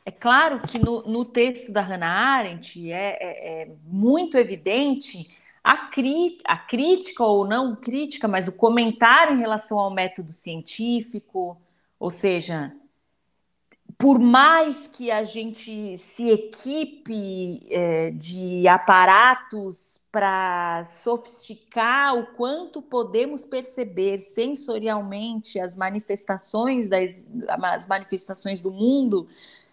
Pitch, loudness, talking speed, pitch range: 220 Hz, -22 LUFS, 110 wpm, 190-245 Hz